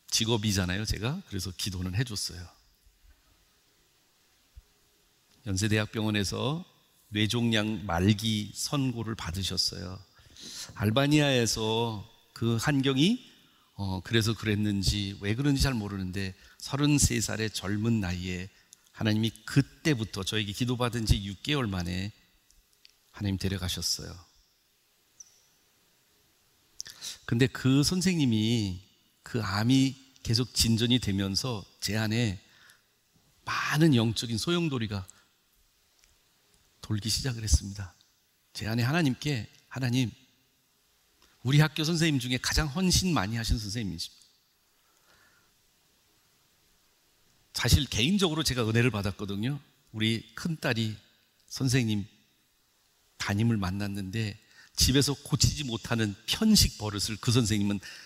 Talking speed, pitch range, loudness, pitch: 235 characters per minute, 100-130 Hz, -28 LUFS, 110 Hz